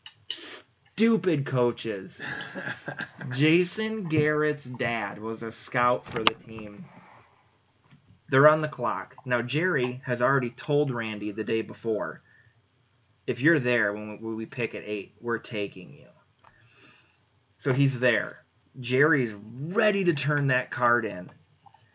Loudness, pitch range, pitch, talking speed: -27 LUFS, 110-140 Hz, 120 Hz, 125 wpm